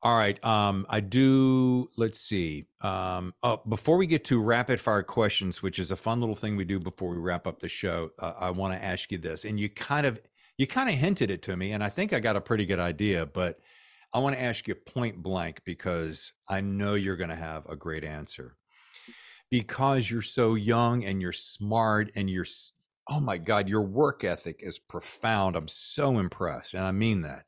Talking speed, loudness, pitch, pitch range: 215 wpm, -29 LUFS, 105 Hz, 95-115 Hz